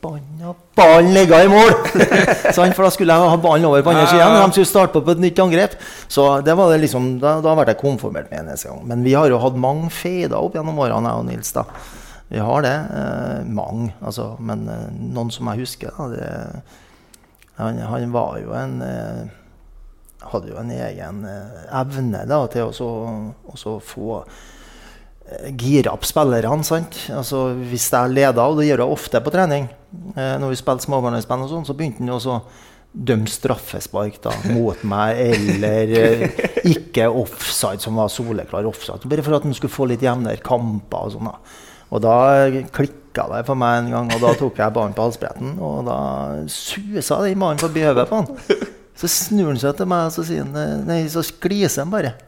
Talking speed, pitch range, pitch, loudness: 185 wpm, 115-160 Hz, 130 Hz, -17 LUFS